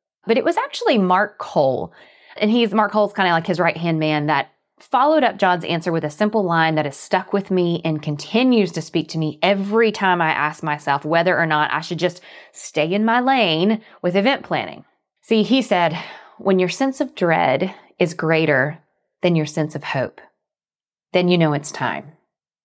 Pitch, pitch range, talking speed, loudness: 180 Hz, 160-210 Hz, 200 wpm, -19 LUFS